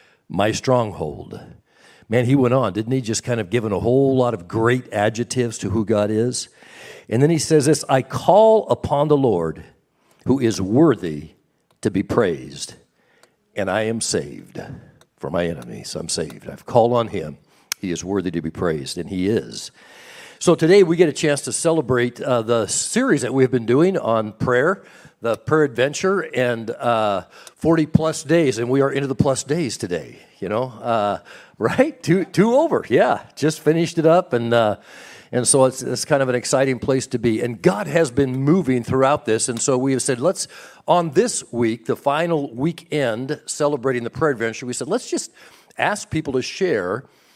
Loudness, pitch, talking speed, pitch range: -20 LUFS, 130 Hz, 190 wpm, 115-155 Hz